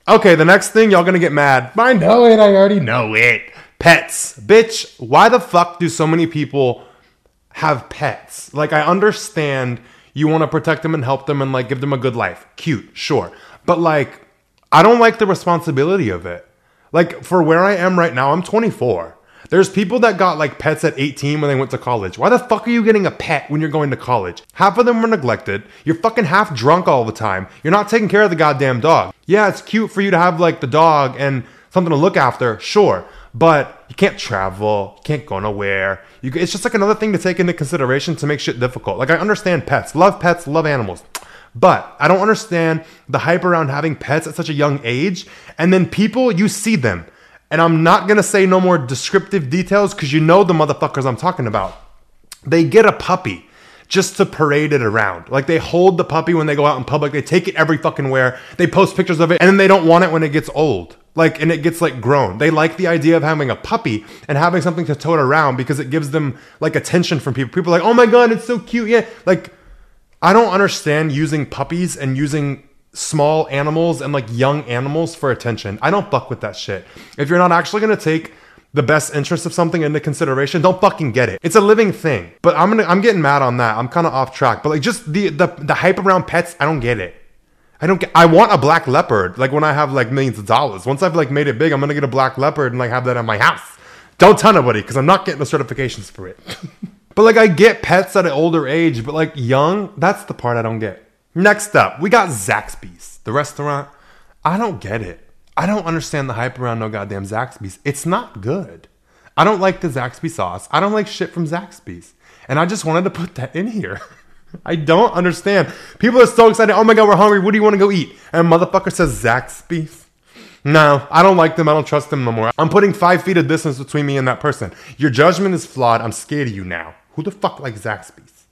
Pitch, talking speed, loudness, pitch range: 160 Hz, 240 wpm, -15 LUFS, 135-185 Hz